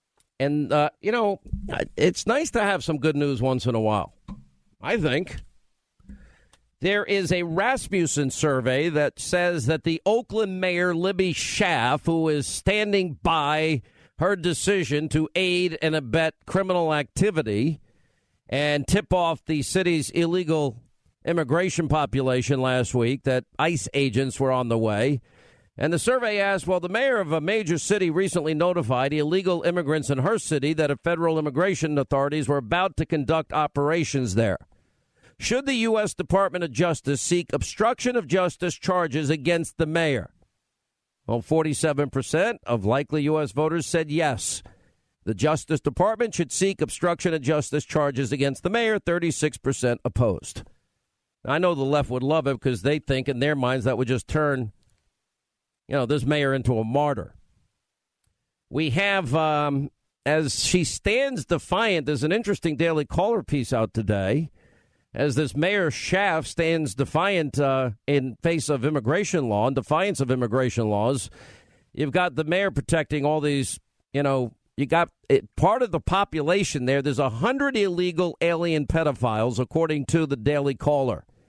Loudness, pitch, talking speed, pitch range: -24 LUFS, 155 Hz, 155 wpm, 135-175 Hz